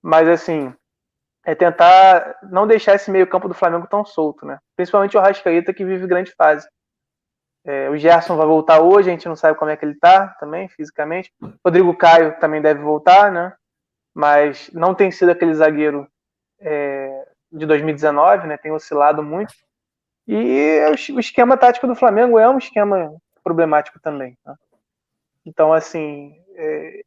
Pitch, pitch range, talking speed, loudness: 170 Hz, 155-190 Hz, 160 wpm, -15 LUFS